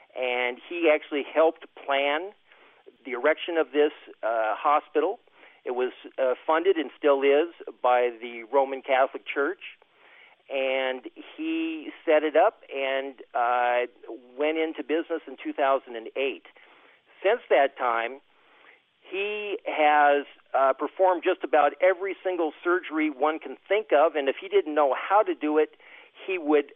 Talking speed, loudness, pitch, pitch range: 140 wpm, -26 LUFS, 150 Hz, 135-185 Hz